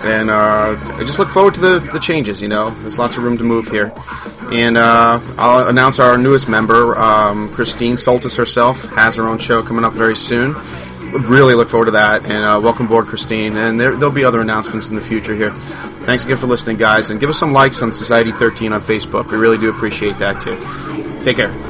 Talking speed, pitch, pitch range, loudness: 225 wpm, 115 Hz, 110-125 Hz, -13 LUFS